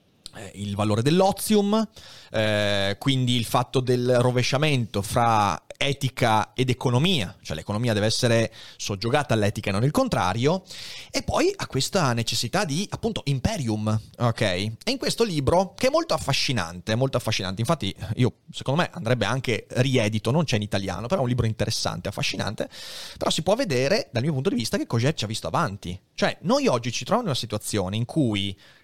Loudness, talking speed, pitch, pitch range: -24 LUFS, 175 wpm, 120 Hz, 110-140 Hz